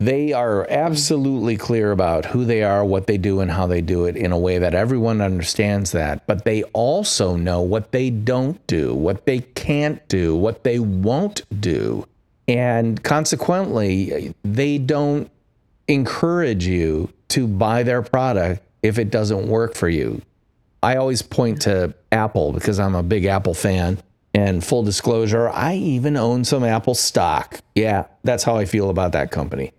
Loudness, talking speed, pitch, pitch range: -20 LUFS, 165 wpm, 110 Hz, 95-125 Hz